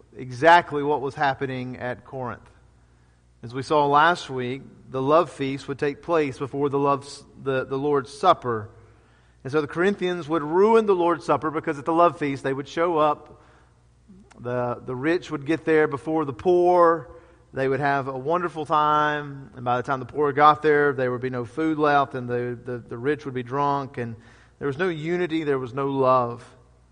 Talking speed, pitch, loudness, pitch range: 195 wpm, 140 Hz, -23 LUFS, 125-155 Hz